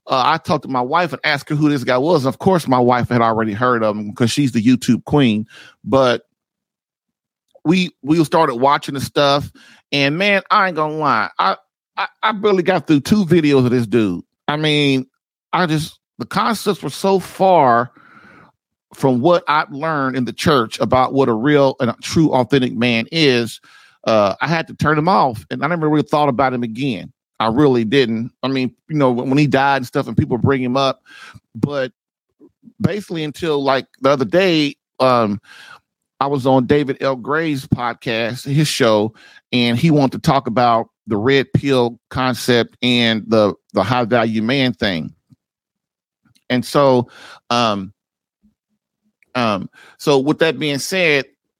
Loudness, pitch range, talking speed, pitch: -17 LUFS, 125-155 Hz, 175 wpm, 135 Hz